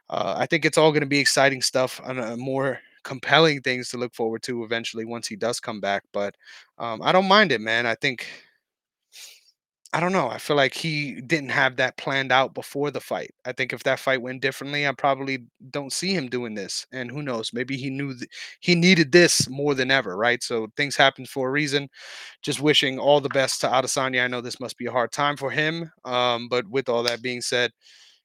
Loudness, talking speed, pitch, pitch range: -23 LUFS, 225 wpm, 135 Hz, 125-145 Hz